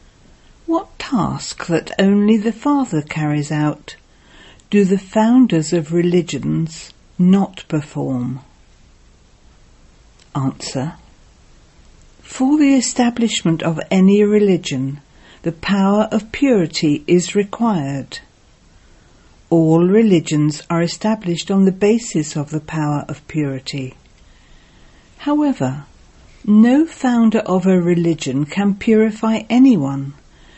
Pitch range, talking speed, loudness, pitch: 150-220 Hz, 95 wpm, -17 LUFS, 175 Hz